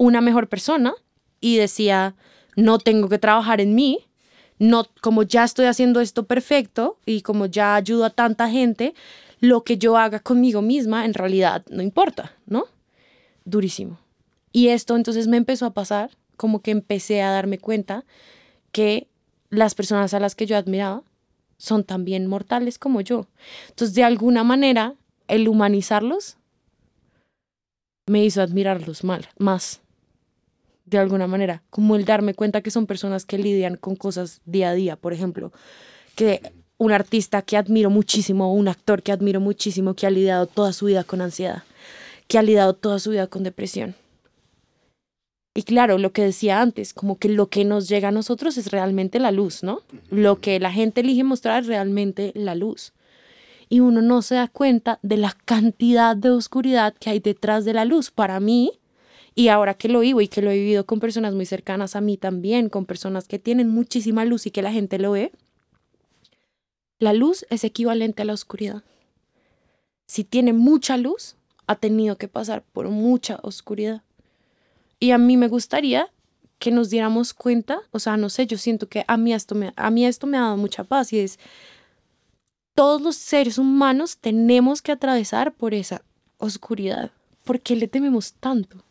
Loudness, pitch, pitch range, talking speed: -20 LUFS, 215 Hz, 200-240 Hz, 175 wpm